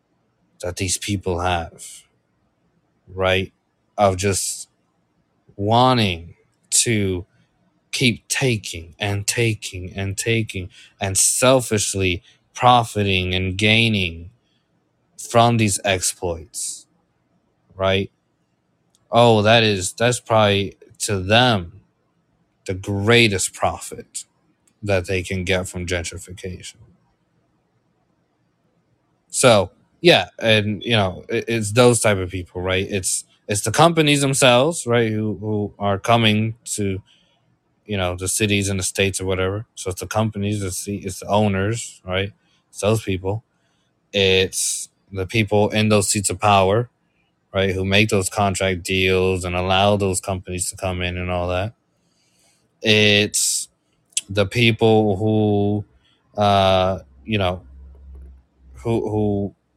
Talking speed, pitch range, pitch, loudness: 115 wpm, 95-110 Hz, 100 Hz, -19 LUFS